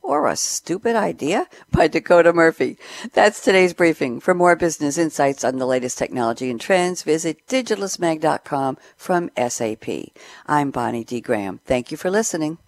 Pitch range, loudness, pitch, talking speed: 130-180 Hz, -20 LUFS, 160 Hz, 150 wpm